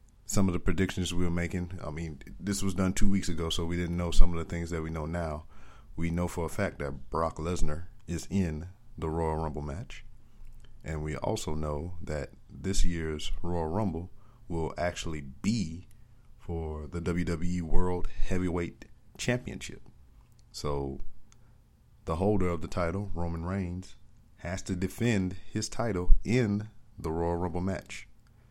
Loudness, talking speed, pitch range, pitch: -33 LUFS, 160 wpm, 80-100 Hz, 90 Hz